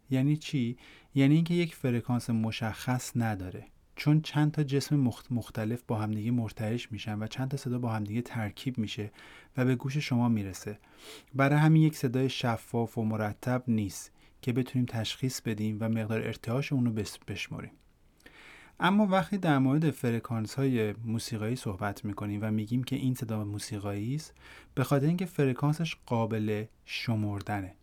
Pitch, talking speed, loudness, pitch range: 120 Hz, 150 wpm, -31 LUFS, 110-135 Hz